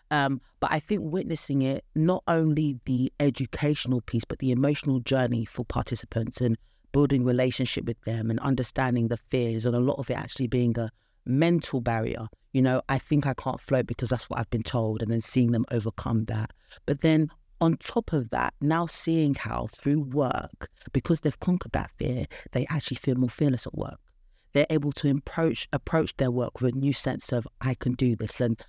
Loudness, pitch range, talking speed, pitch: -27 LUFS, 120-145 Hz, 200 wpm, 130 Hz